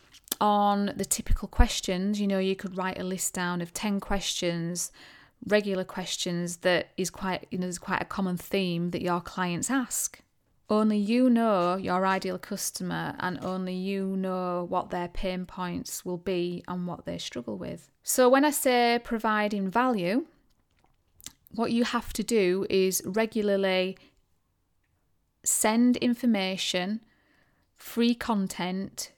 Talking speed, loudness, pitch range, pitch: 140 wpm, -28 LUFS, 180-215 Hz, 190 Hz